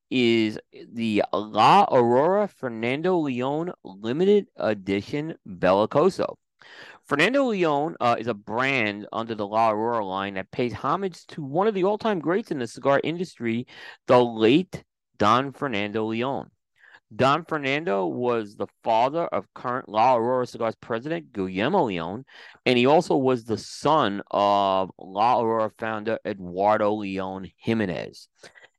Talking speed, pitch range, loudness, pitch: 135 wpm, 105-145 Hz, -24 LUFS, 120 Hz